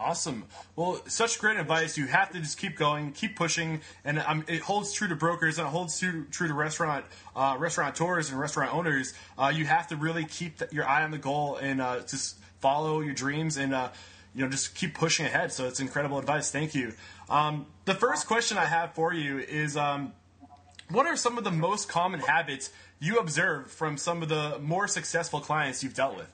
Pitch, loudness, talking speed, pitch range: 155 Hz, -29 LUFS, 215 wpm, 135-170 Hz